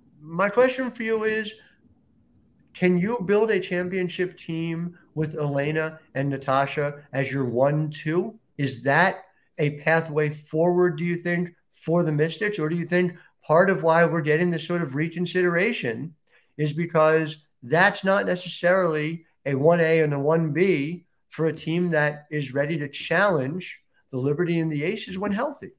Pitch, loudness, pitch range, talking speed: 165 Hz, -24 LUFS, 150-180 Hz, 160 wpm